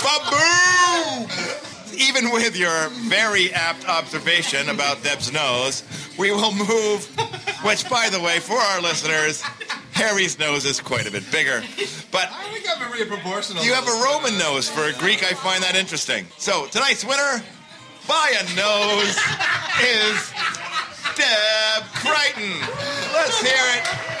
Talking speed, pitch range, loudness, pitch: 140 wpm, 165-250 Hz, -19 LUFS, 205 Hz